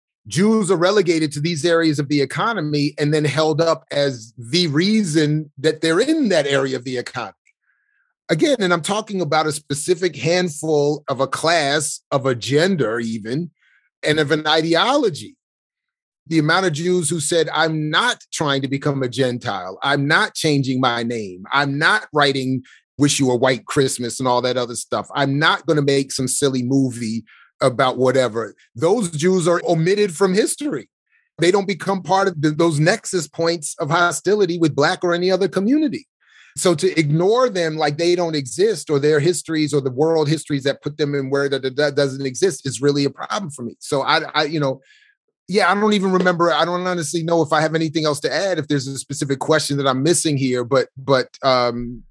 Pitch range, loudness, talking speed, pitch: 140-175 Hz, -19 LUFS, 195 wpm, 155 Hz